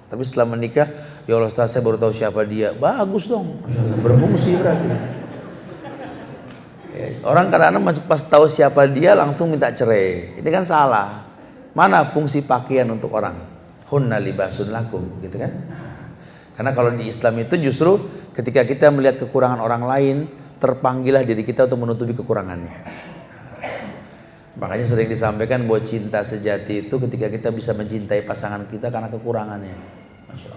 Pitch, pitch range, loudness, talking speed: 125 Hz, 110-145 Hz, -19 LUFS, 135 wpm